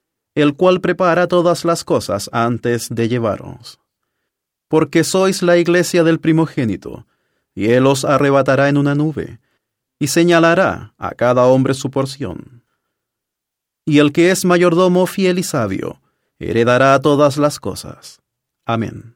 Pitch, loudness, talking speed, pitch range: 145 Hz, -15 LUFS, 130 wpm, 125-170 Hz